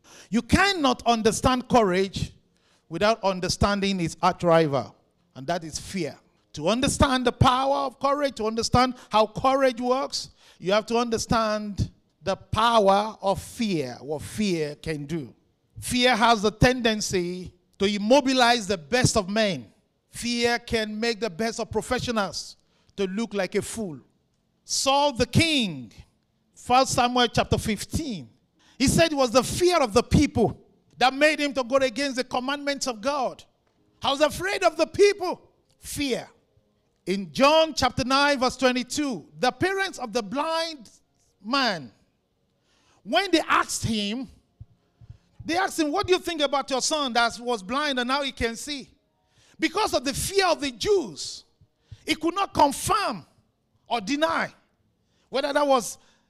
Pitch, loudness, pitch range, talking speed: 245 Hz, -24 LUFS, 210-280 Hz, 150 wpm